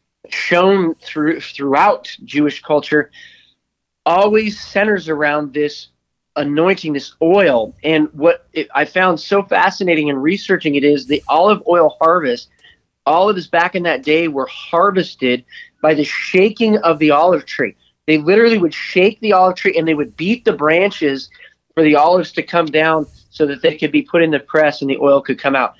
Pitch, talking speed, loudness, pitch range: 160 Hz, 180 wpm, -15 LUFS, 150-190 Hz